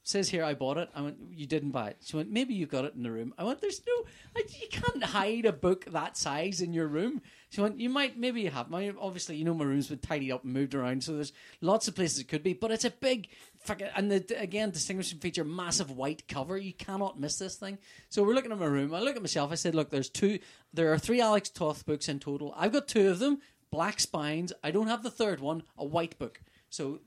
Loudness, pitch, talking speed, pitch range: -32 LUFS, 175 Hz, 265 wpm, 150-210 Hz